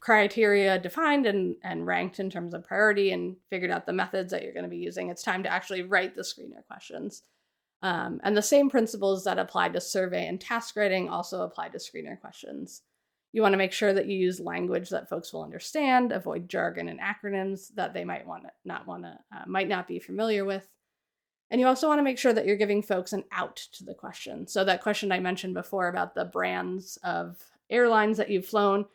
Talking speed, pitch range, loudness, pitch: 220 wpm, 185-215 Hz, -28 LUFS, 195 Hz